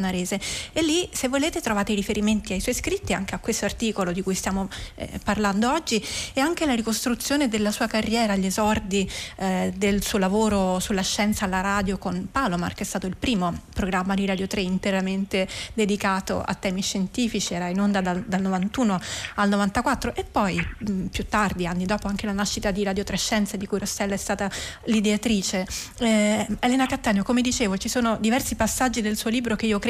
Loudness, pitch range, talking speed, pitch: -24 LUFS, 195-230 Hz, 195 wpm, 205 Hz